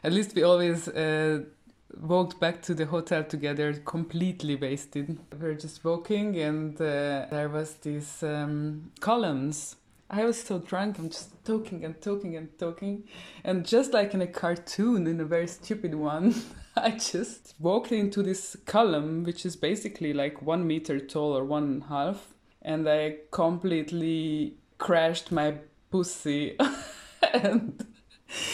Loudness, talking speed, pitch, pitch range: -29 LUFS, 150 wpm, 165 Hz, 150-190 Hz